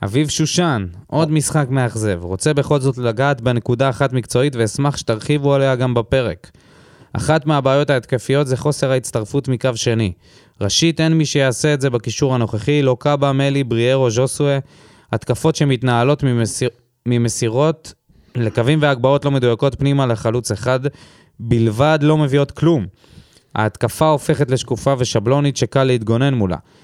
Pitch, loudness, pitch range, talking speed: 130 Hz, -17 LUFS, 120-145 Hz, 135 wpm